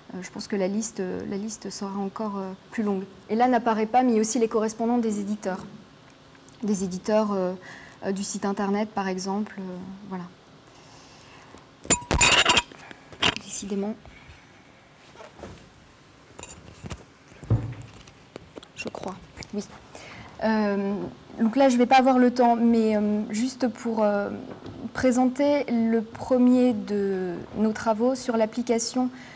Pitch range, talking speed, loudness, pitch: 195-235 Hz, 125 wpm, -24 LUFS, 215 Hz